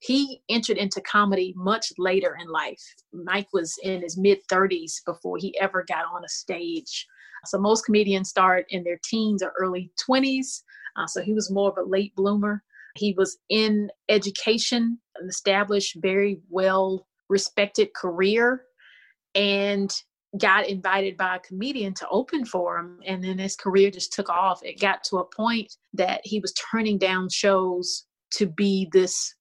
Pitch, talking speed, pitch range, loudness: 195 Hz, 165 wpm, 185-215 Hz, -24 LUFS